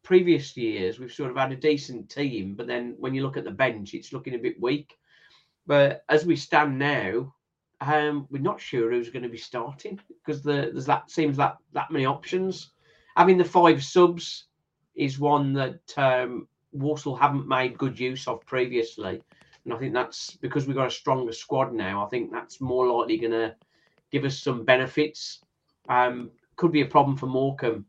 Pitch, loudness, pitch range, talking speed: 140 Hz, -25 LUFS, 125-150 Hz, 195 wpm